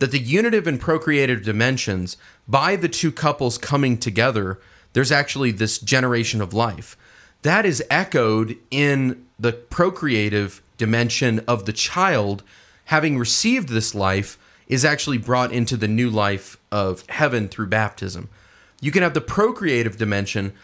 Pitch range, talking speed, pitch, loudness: 105-140 Hz, 140 wpm, 120 Hz, -20 LUFS